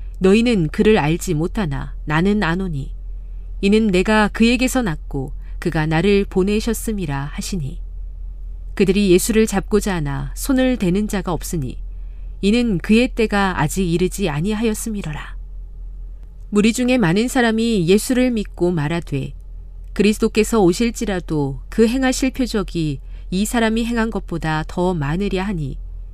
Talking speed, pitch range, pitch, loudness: 290 characters per minute, 155-220 Hz, 190 Hz, -19 LUFS